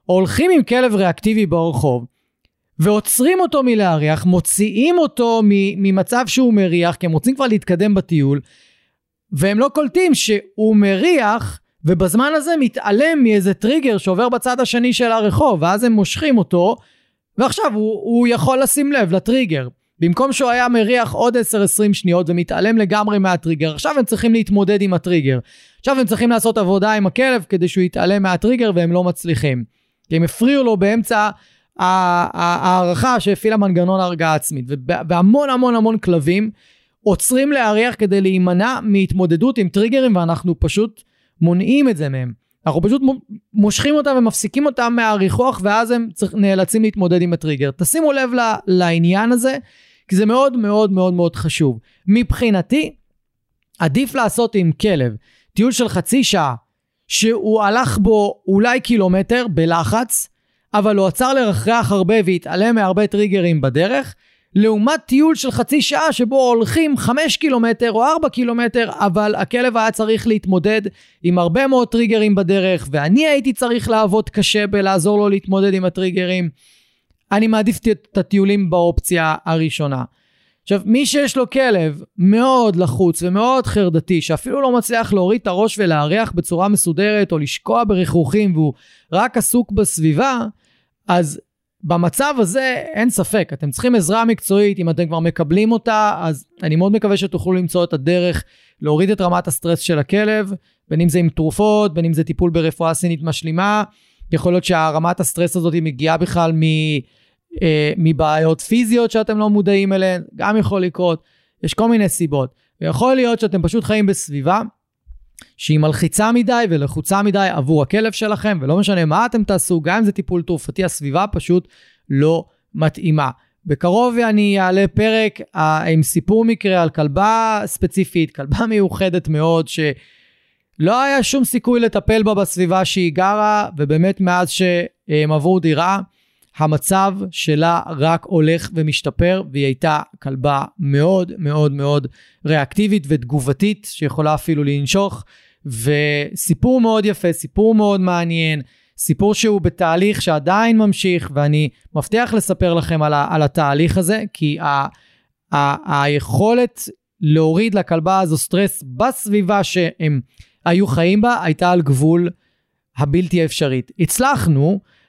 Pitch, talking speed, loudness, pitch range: 195 Hz, 140 wpm, -16 LUFS, 165-220 Hz